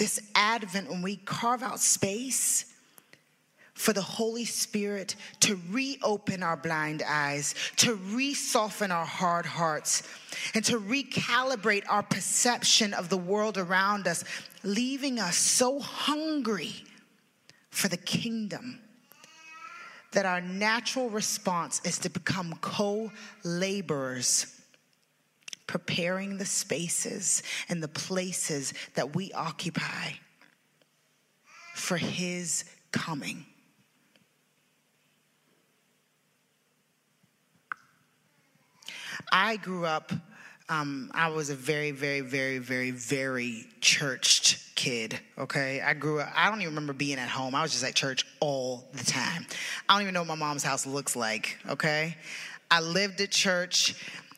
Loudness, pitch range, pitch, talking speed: -28 LUFS, 155-220 Hz, 185 Hz, 120 wpm